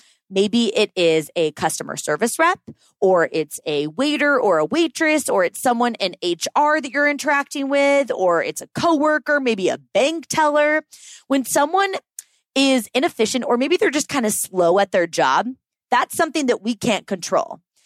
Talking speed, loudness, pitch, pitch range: 170 wpm, -19 LUFS, 270 Hz, 200-300 Hz